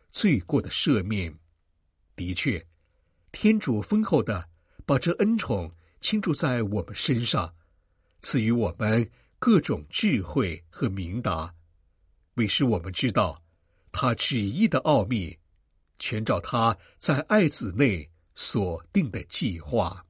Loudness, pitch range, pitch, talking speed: -26 LUFS, 85-125 Hz, 100 Hz, 175 characters per minute